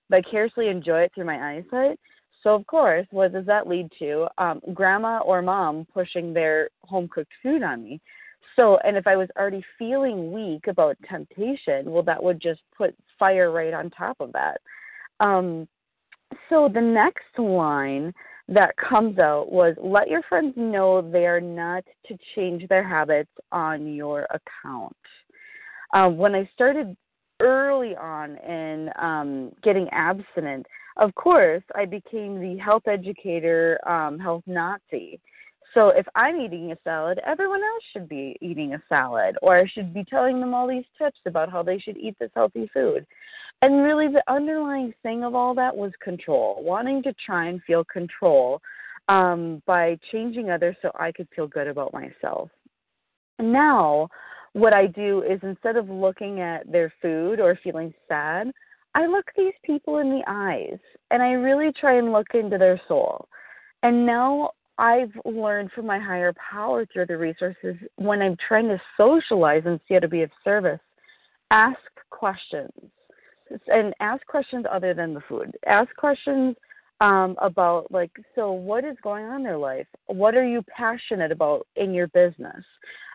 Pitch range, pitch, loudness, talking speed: 175-245 Hz, 195 Hz, -23 LUFS, 165 wpm